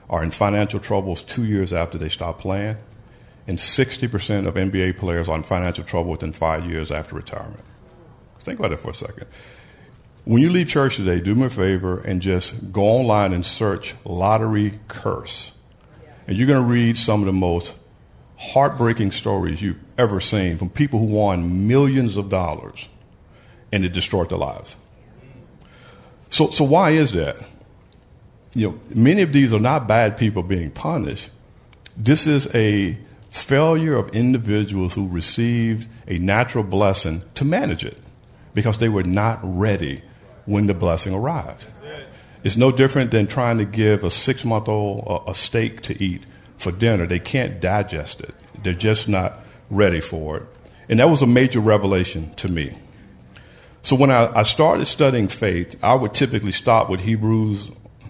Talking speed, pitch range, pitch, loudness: 165 wpm, 95-115 Hz, 105 Hz, -20 LUFS